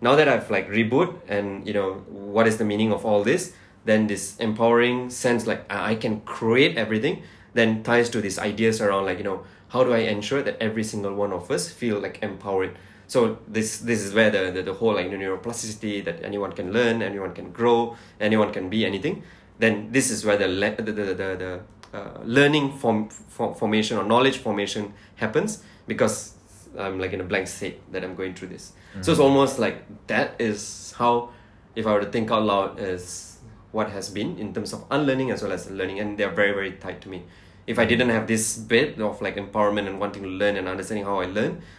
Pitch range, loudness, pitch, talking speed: 95-115 Hz, -24 LUFS, 105 Hz, 215 wpm